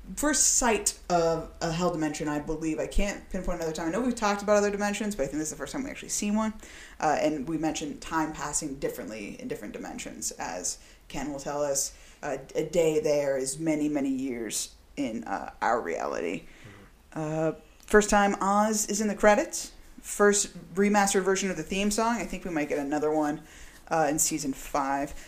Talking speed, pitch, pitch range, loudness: 200 wpm, 170 Hz, 150-205 Hz, -28 LUFS